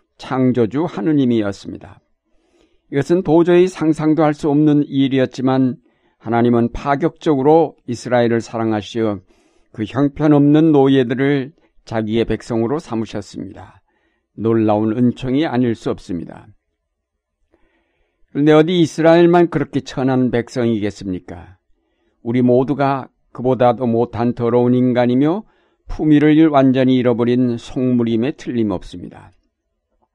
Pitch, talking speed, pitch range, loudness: 125 Hz, 285 characters per minute, 115-145 Hz, -16 LUFS